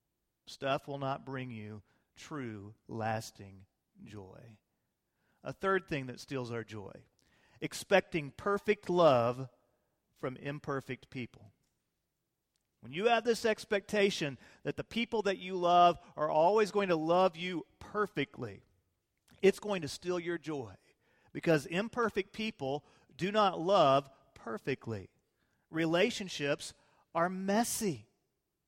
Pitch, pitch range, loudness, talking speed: 150 Hz, 125-195 Hz, -33 LUFS, 115 wpm